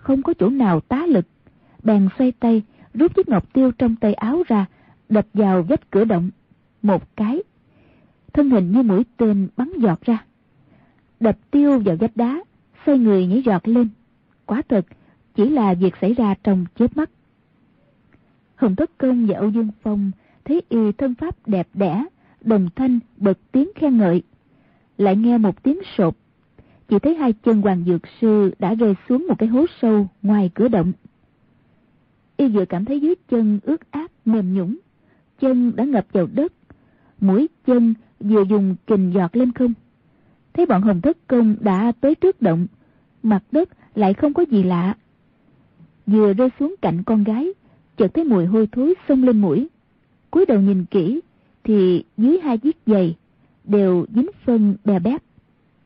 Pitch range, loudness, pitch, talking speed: 200-265 Hz, -19 LUFS, 225 Hz, 170 wpm